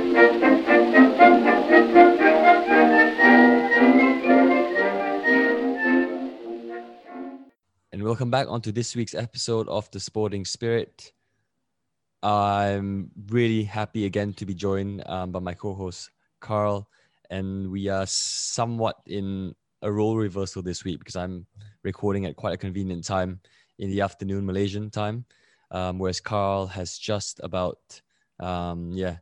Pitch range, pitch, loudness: 95-110 Hz, 100 Hz, -22 LUFS